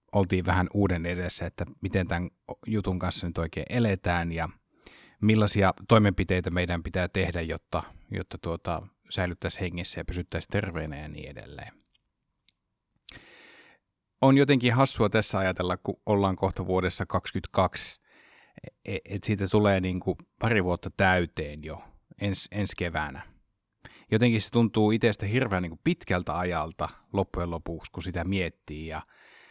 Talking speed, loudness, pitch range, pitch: 135 wpm, -28 LUFS, 85-100 Hz, 95 Hz